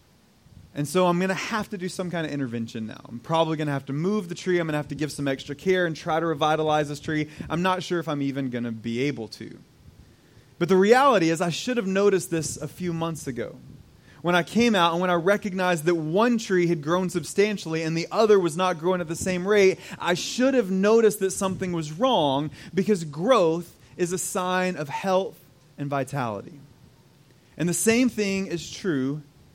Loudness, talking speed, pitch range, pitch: -24 LUFS, 220 wpm, 145-190 Hz, 170 Hz